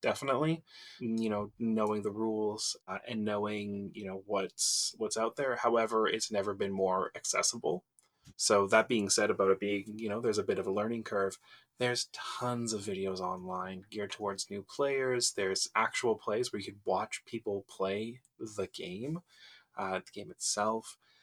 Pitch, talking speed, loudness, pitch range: 105 Hz, 170 wpm, -33 LUFS, 100-115 Hz